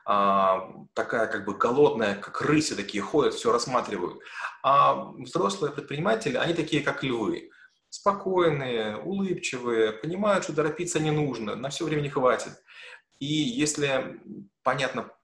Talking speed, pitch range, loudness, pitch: 125 wpm, 130-185 Hz, -26 LUFS, 150 Hz